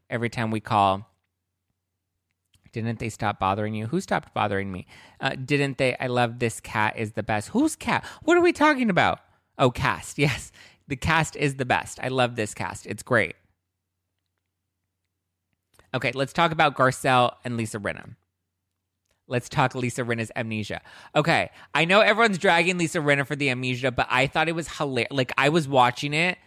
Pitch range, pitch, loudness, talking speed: 95-140 Hz, 120 Hz, -24 LUFS, 175 wpm